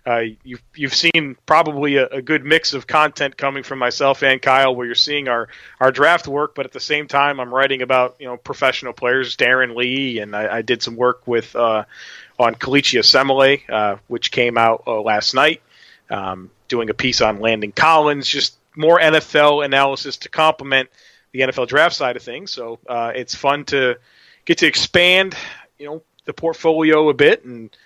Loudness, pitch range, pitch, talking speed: -16 LUFS, 125-150 Hz, 135 Hz, 190 wpm